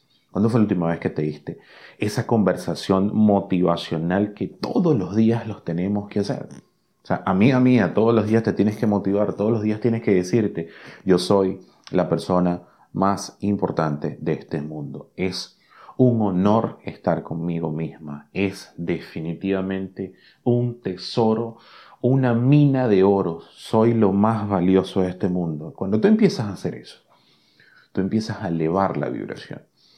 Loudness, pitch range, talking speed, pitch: -22 LUFS, 85-110 Hz, 160 wpm, 95 Hz